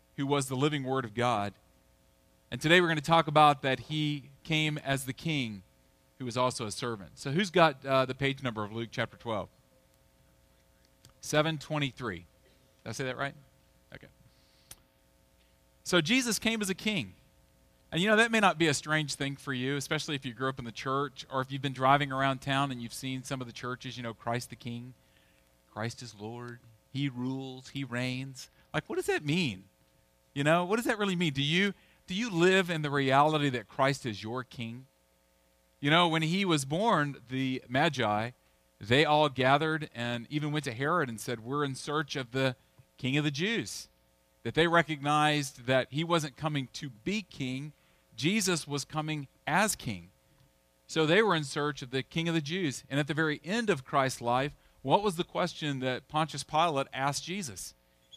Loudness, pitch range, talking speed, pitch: -30 LUFS, 120-155 Hz, 195 wpm, 135 Hz